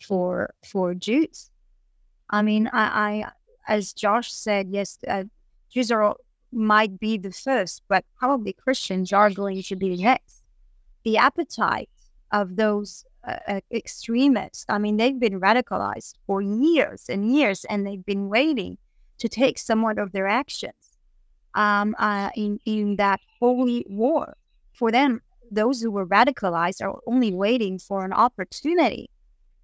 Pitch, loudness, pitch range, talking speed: 215 Hz, -23 LUFS, 200-245 Hz, 145 wpm